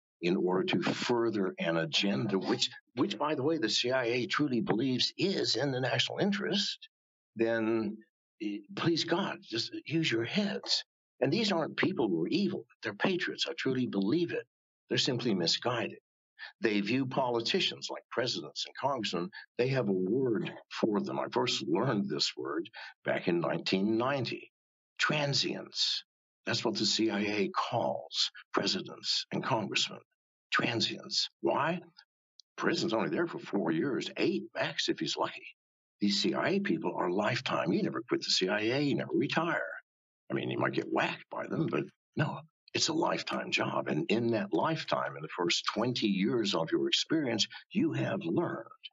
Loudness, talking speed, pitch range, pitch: -32 LUFS, 160 wpm, 110-165 Hz, 125 Hz